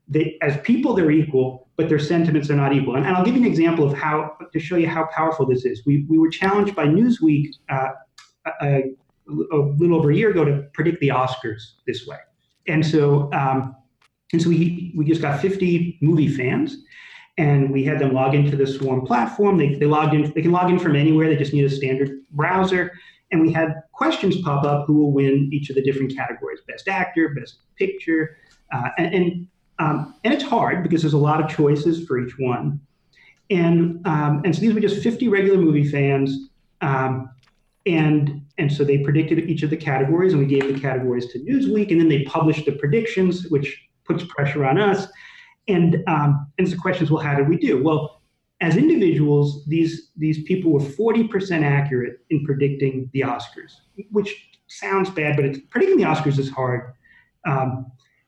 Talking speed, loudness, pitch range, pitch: 200 wpm, -20 LUFS, 140-175 Hz, 155 Hz